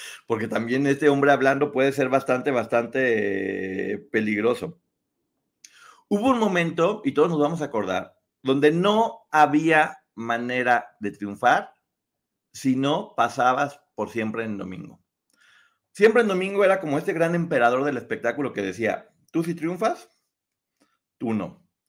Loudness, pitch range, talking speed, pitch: -23 LUFS, 125-165 Hz, 145 wpm, 145 Hz